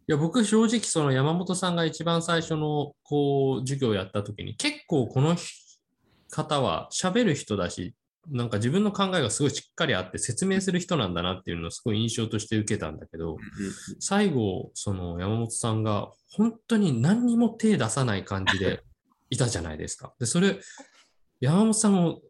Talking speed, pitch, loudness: 340 characters per minute, 135 Hz, -26 LUFS